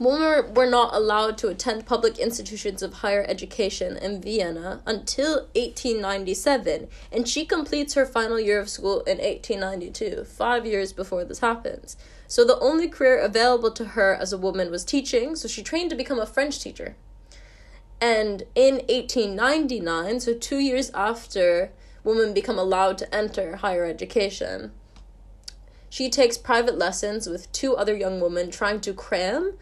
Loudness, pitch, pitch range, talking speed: -24 LUFS, 225 Hz, 195-260 Hz, 155 wpm